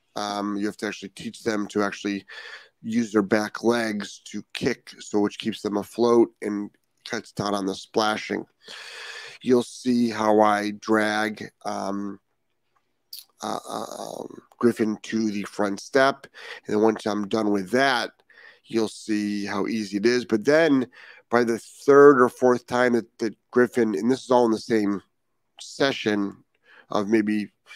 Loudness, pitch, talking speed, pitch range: -24 LUFS, 110 Hz, 160 wpm, 105-120 Hz